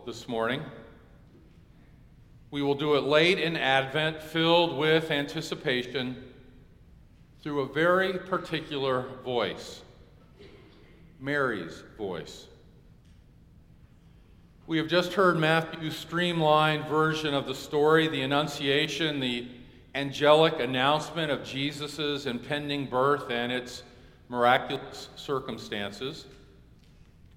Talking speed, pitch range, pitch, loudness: 90 wpm, 125-155 Hz, 145 Hz, -27 LUFS